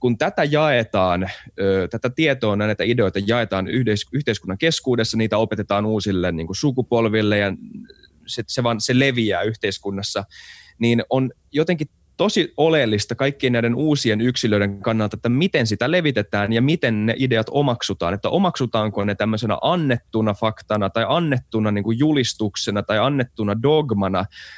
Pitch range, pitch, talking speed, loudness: 105-130 Hz, 115 Hz, 135 wpm, -20 LUFS